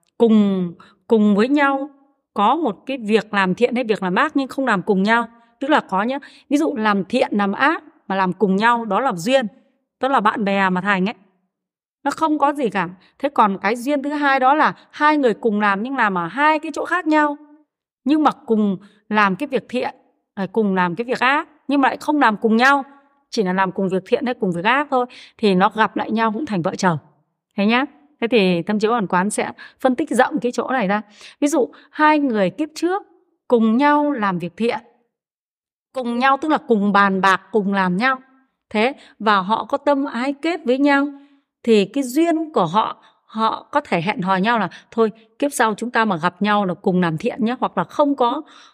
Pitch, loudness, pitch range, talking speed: 235 Hz, -19 LUFS, 200-280 Hz, 225 wpm